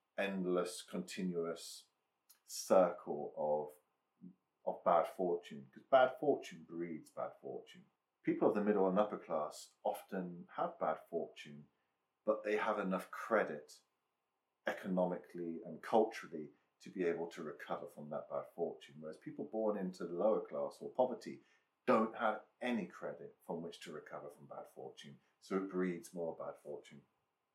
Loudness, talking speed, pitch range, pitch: -39 LUFS, 145 wpm, 80-95 Hz, 85 Hz